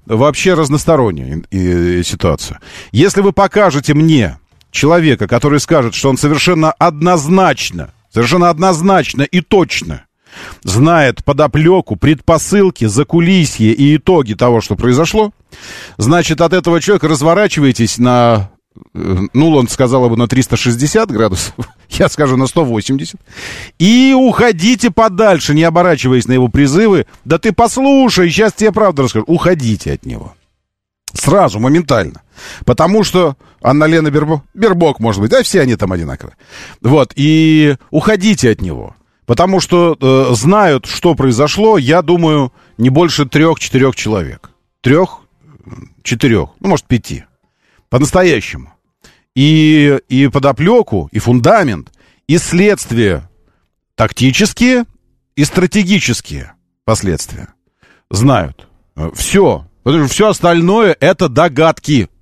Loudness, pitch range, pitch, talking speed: -11 LUFS, 115-180 Hz, 150 Hz, 115 wpm